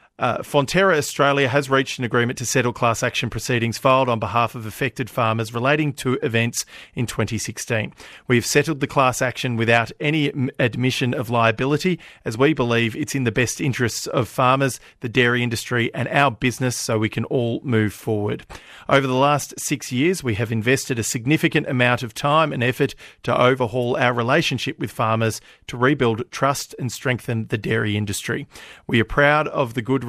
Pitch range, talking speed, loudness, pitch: 115-140 Hz, 180 wpm, -20 LUFS, 125 Hz